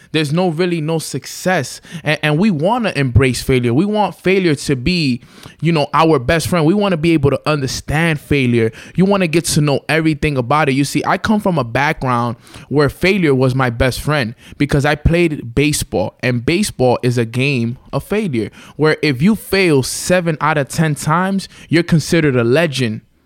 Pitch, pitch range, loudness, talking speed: 150 Hz, 130-170 Hz, -15 LUFS, 195 wpm